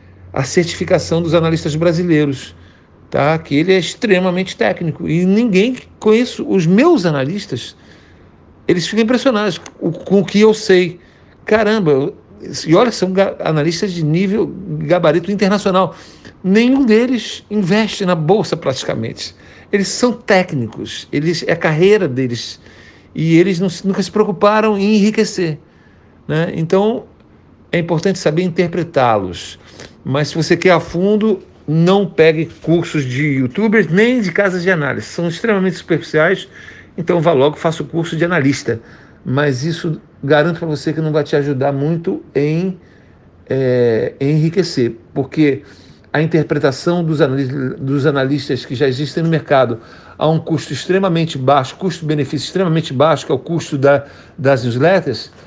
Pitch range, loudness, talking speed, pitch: 140-190 Hz, -15 LUFS, 140 wpm, 165 Hz